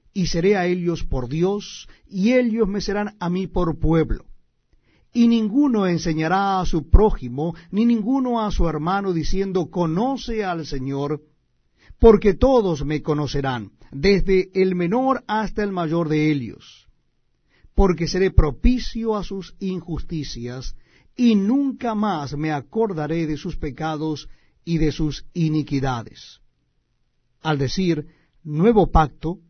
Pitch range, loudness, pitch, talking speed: 150-205 Hz, -21 LUFS, 175 Hz, 130 wpm